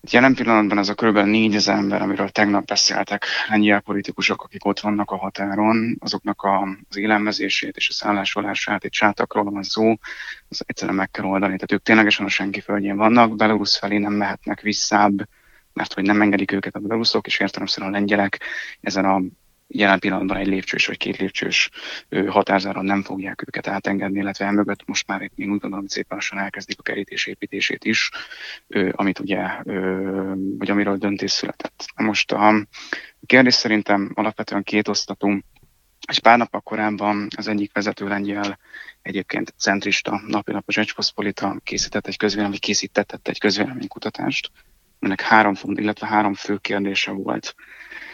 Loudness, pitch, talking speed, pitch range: -20 LUFS, 100 Hz, 155 wpm, 100-105 Hz